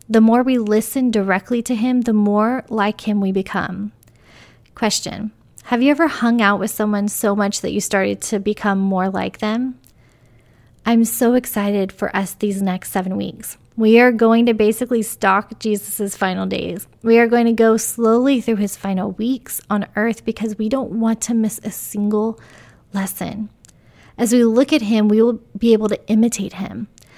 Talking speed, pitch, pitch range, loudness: 180 wpm, 215 Hz, 200-230 Hz, -18 LUFS